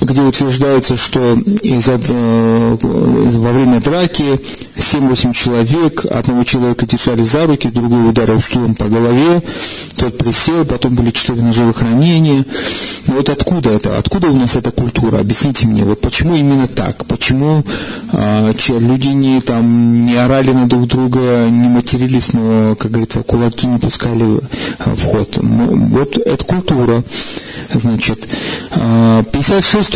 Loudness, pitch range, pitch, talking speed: -12 LUFS, 115-135 Hz, 120 Hz, 135 wpm